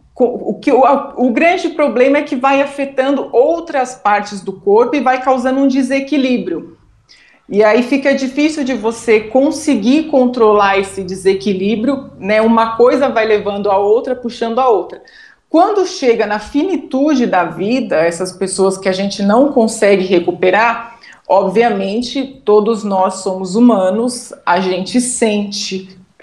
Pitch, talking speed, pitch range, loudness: 235 Hz, 140 wpm, 205-275 Hz, -13 LUFS